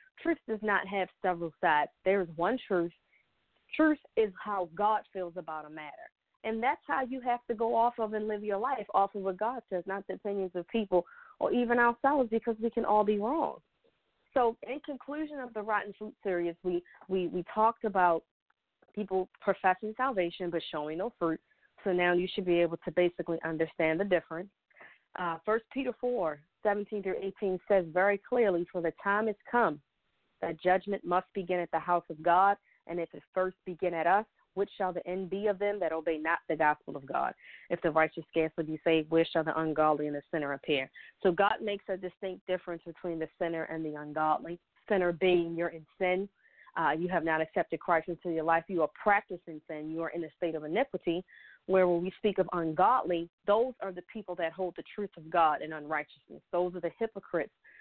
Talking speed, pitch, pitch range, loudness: 205 wpm, 185 Hz, 165-205 Hz, -32 LUFS